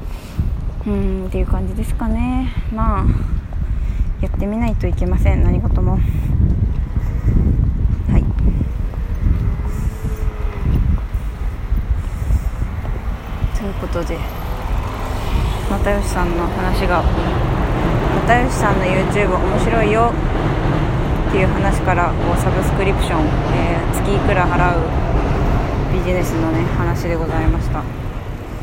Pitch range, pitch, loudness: 85-100 Hz, 90 Hz, -19 LUFS